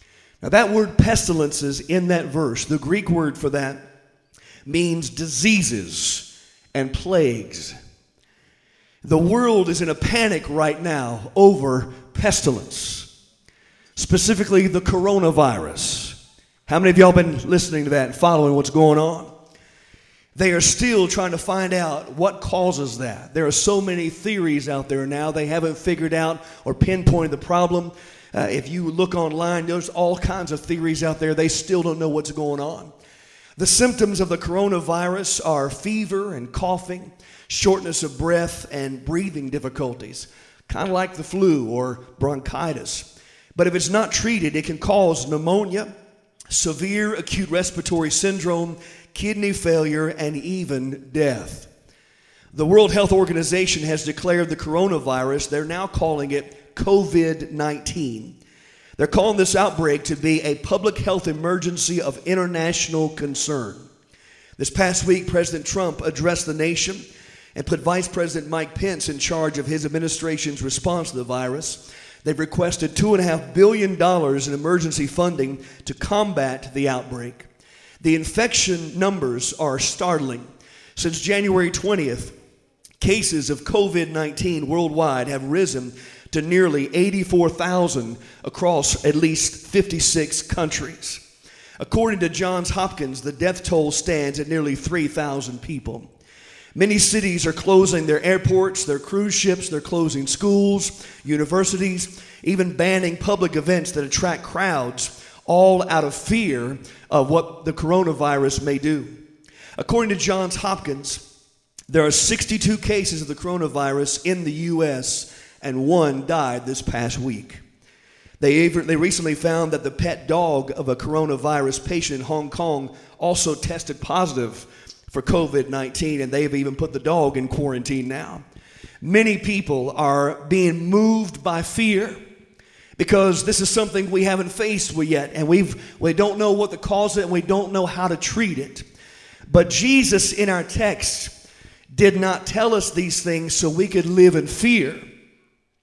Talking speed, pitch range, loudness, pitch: 145 wpm, 145-185 Hz, -20 LUFS, 165 Hz